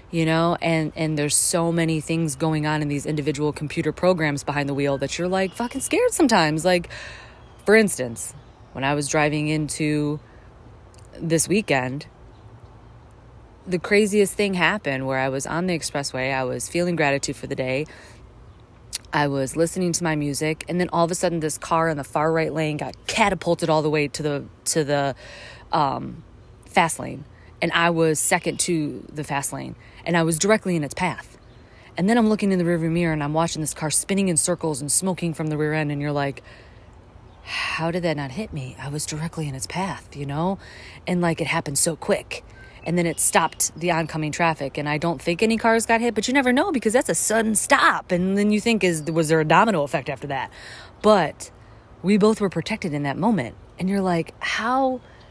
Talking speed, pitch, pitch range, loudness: 205 wpm, 155 Hz, 140-175 Hz, -22 LUFS